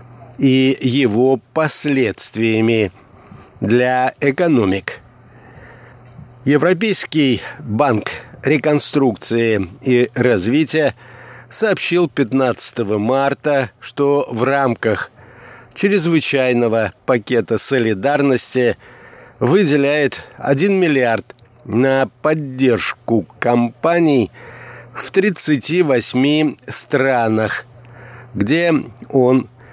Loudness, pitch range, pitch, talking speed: -16 LUFS, 120-145 Hz, 130 Hz, 60 wpm